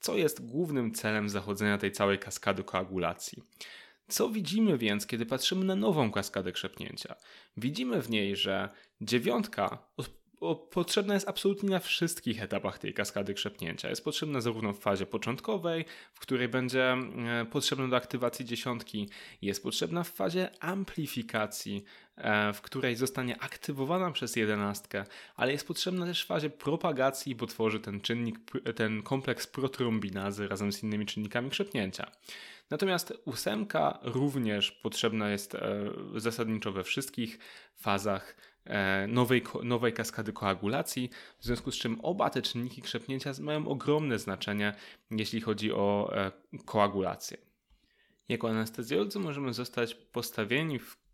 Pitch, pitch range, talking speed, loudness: 120 Hz, 105-140 Hz, 130 wpm, -32 LUFS